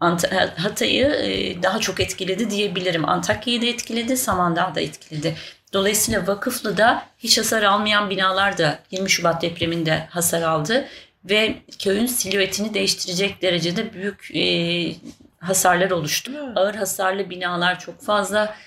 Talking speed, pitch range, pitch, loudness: 120 wpm, 175-215 Hz, 195 Hz, -20 LUFS